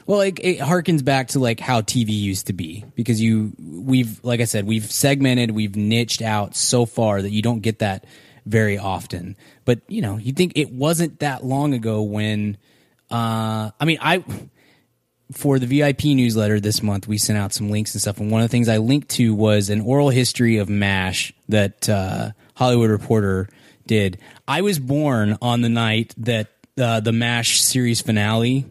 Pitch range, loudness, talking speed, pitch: 105-130 Hz, -20 LUFS, 190 wpm, 115 Hz